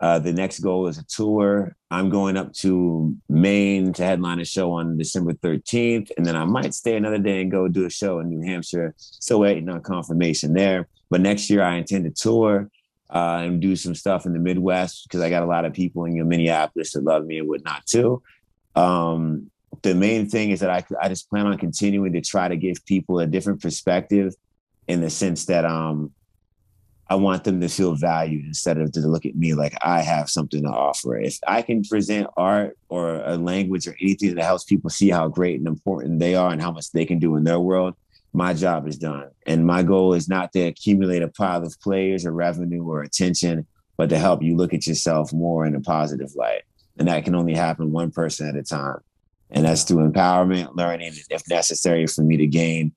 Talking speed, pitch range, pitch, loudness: 220 wpm, 80-95 Hz, 90 Hz, -22 LUFS